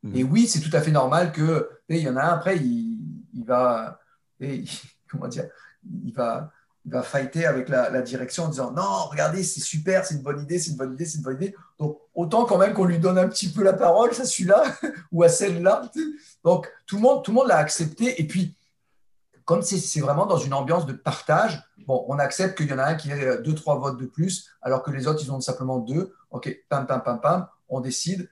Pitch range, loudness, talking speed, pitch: 140-190 Hz, -23 LUFS, 240 wpm, 165 Hz